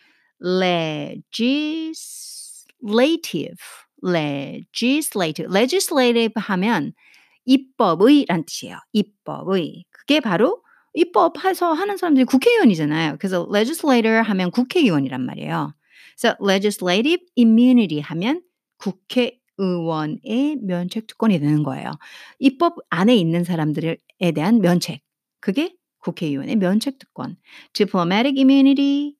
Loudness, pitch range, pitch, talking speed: -19 LUFS, 180-280 Hz, 225 Hz, 365 characters per minute